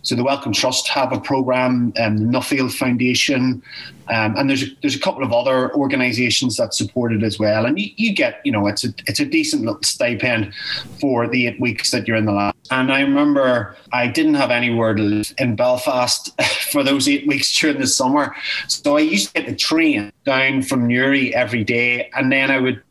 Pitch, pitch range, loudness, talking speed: 125 Hz, 120-140 Hz, -17 LUFS, 215 wpm